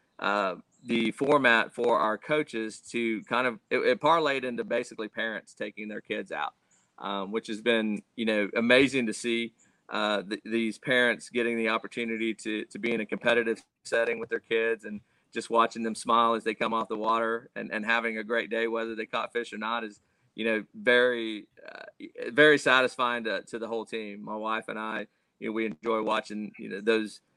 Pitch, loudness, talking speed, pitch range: 115 Hz, -28 LUFS, 200 wpm, 110-115 Hz